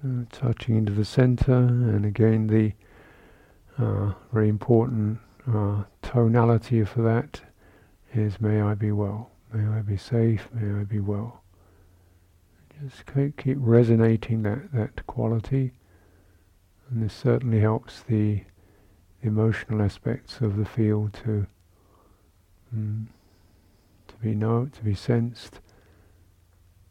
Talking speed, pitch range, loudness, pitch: 115 wpm, 100-115 Hz, -25 LUFS, 105 Hz